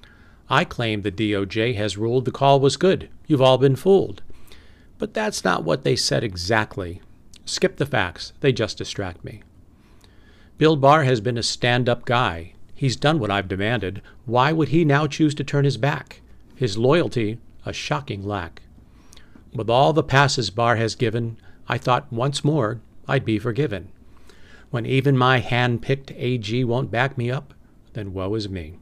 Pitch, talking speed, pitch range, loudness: 120 Hz, 170 wpm, 105-140 Hz, -21 LUFS